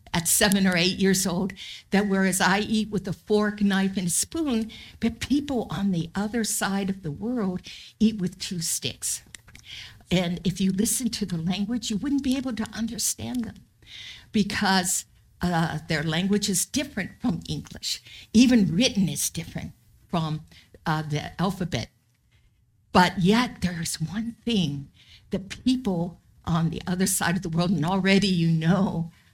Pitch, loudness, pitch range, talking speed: 190 Hz, -25 LUFS, 165-210 Hz, 160 wpm